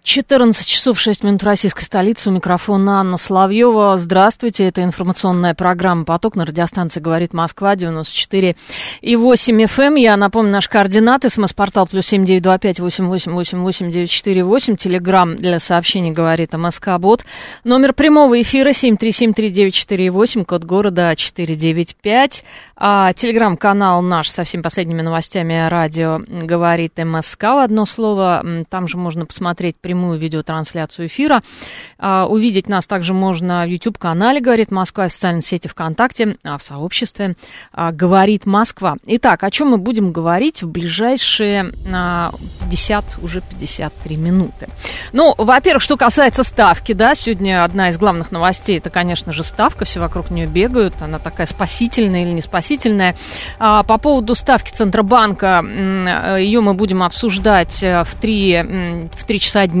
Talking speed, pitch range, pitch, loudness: 130 wpm, 175-220 Hz, 190 Hz, -14 LUFS